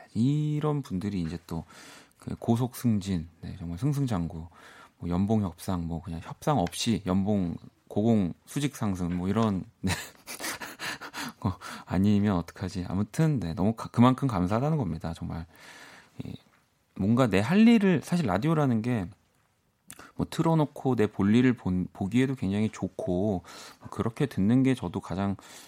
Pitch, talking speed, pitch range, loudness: 105 Hz, 270 characters per minute, 90-130 Hz, -28 LUFS